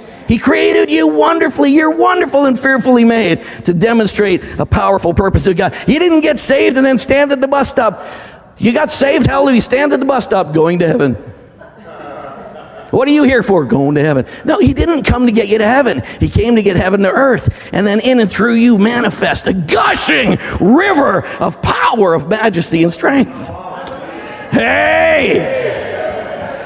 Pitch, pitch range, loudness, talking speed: 235 Hz, 195-280 Hz, -11 LUFS, 180 wpm